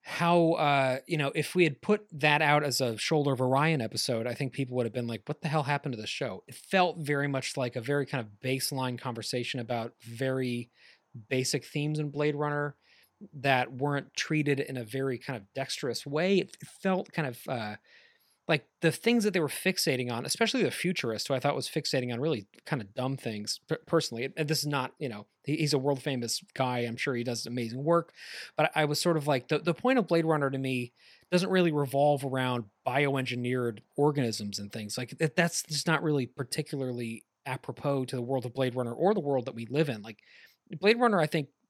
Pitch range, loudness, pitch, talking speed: 125-155 Hz, -30 LUFS, 140 Hz, 215 wpm